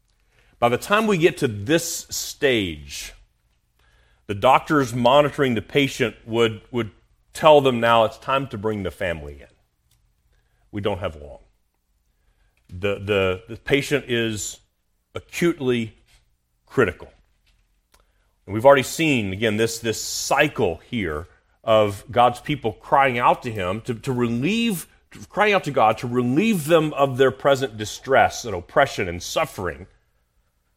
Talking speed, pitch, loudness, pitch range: 140 wpm, 115 Hz, -21 LUFS, 95-140 Hz